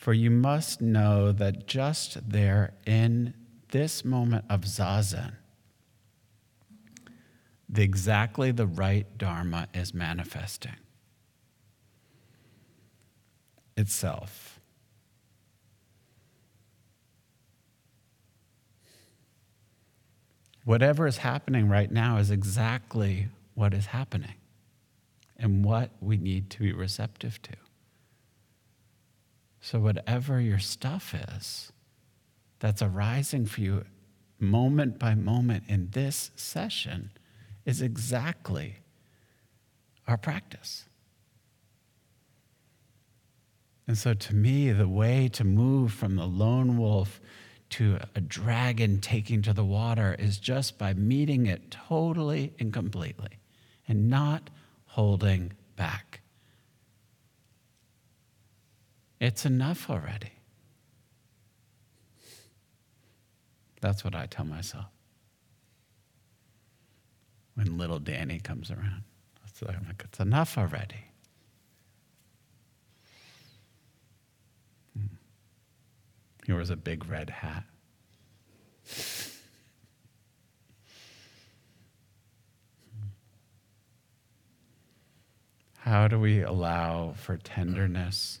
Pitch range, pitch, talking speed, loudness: 105-120 Hz, 110 Hz, 80 wpm, -29 LUFS